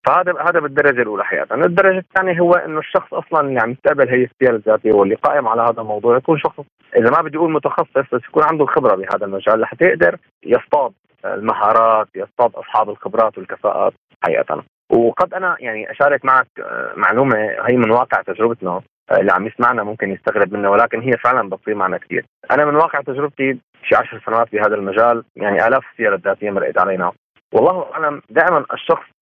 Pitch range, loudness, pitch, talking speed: 115-165 Hz, -16 LUFS, 140 Hz, 175 wpm